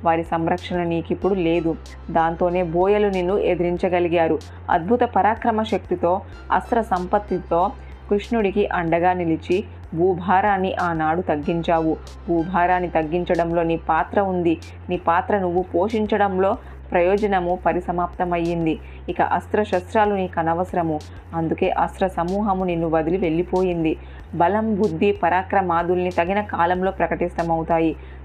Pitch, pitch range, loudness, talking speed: 175 Hz, 170-190 Hz, -21 LUFS, 100 wpm